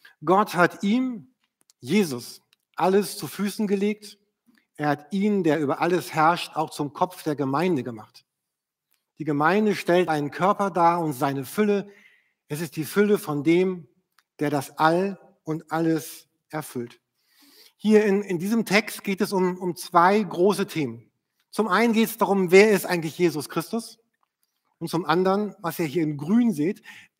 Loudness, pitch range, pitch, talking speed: -23 LUFS, 155-205 Hz, 180 Hz, 160 wpm